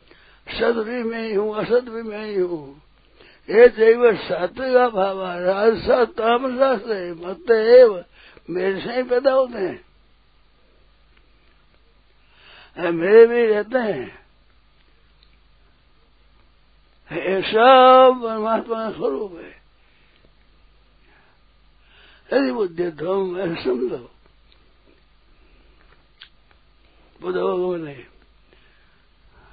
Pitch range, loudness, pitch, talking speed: 180-255 Hz, -18 LUFS, 220 Hz, 65 wpm